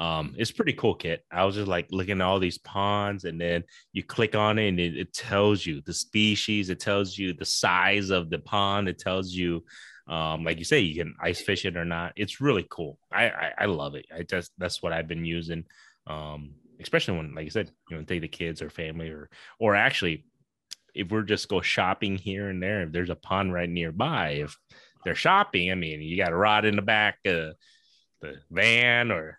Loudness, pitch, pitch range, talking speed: -26 LUFS, 90 Hz, 85-100 Hz, 225 wpm